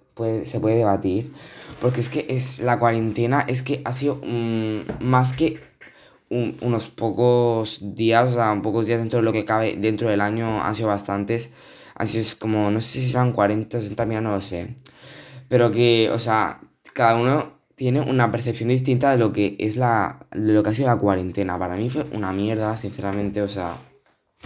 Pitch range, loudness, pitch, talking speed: 105-125 Hz, -22 LUFS, 115 Hz, 195 wpm